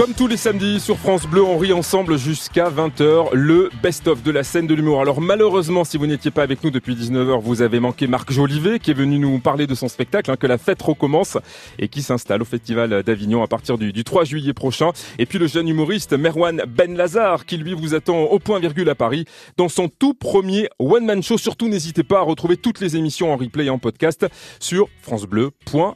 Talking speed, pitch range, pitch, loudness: 225 wpm, 130-185 Hz, 155 Hz, -18 LUFS